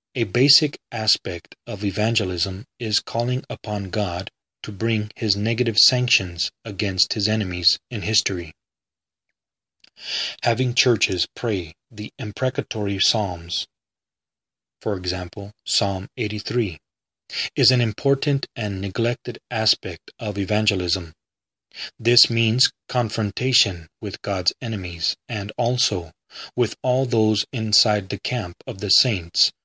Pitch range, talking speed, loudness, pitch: 95-120 Hz, 110 wpm, -21 LUFS, 105 Hz